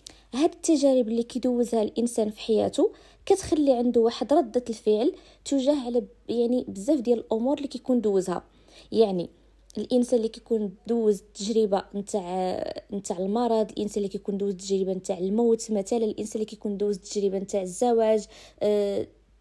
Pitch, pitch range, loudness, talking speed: 225 Hz, 205-250 Hz, -26 LUFS, 140 wpm